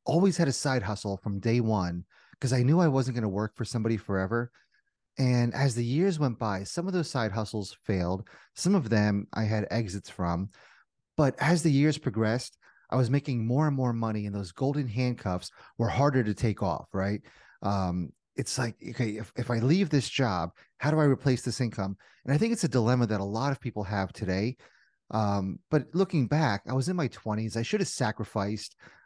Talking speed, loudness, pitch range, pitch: 210 wpm, -29 LUFS, 105-140 Hz, 120 Hz